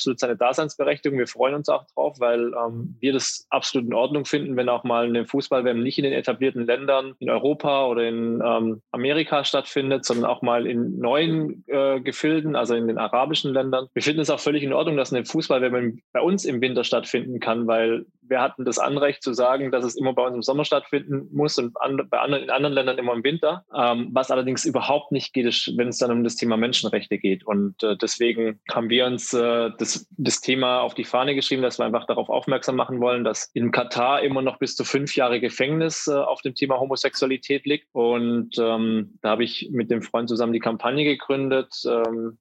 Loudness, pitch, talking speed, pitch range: -23 LUFS, 125 Hz, 215 wpm, 120-140 Hz